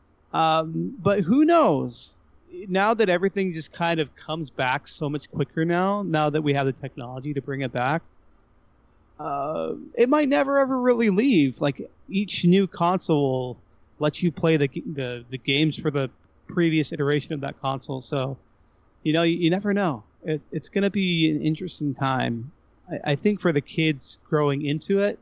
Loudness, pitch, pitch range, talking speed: -24 LUFS, 155 Hz, 140-185 Hz, 175 wpm